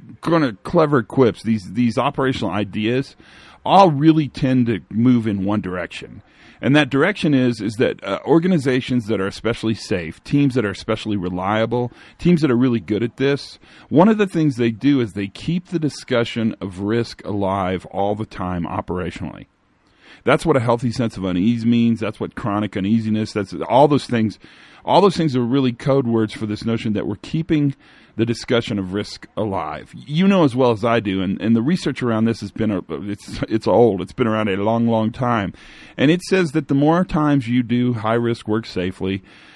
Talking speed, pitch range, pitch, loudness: 195 wpm, 105-140 Hz, 115 Hz, -19 LUFS